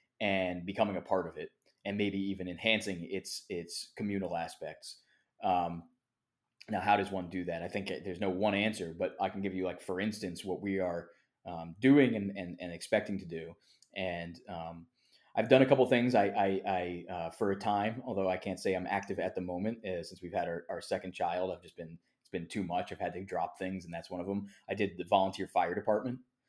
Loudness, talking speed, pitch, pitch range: -34 LUFS, 230 wpm, 95 Hz, 90-105 Hz